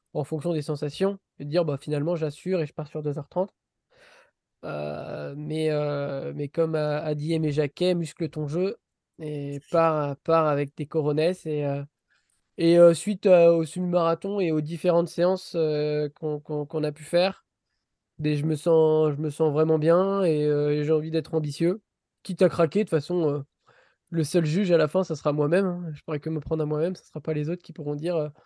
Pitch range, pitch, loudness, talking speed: 150-170 Hz, 160 Hz, -25 LUFS, 210 wpm